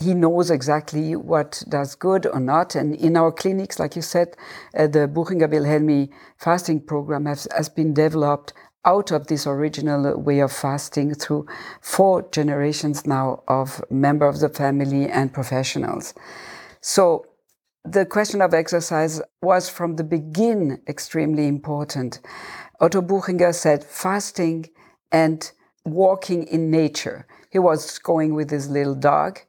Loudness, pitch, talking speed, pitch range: -21 LUFS, 155 Hz, 140 wpm, 145-170 Hz